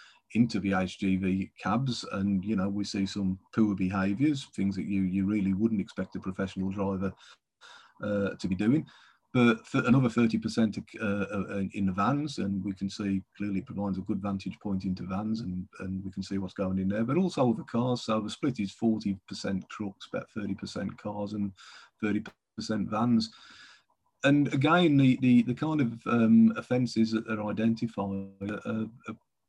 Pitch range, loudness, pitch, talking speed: 95-115 Hz, -29 LUFS, 100 Hz, 185 wpm